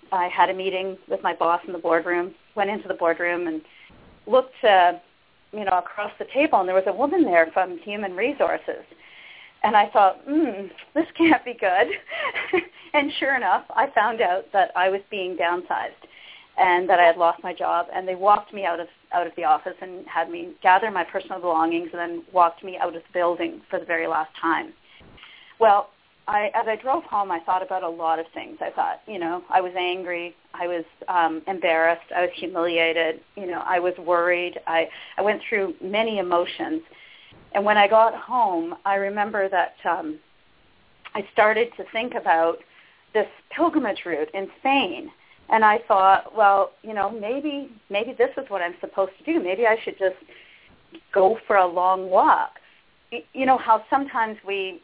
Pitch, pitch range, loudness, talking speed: 195 Hz, 175-225 Hz, -22 LUFS, 190 wpm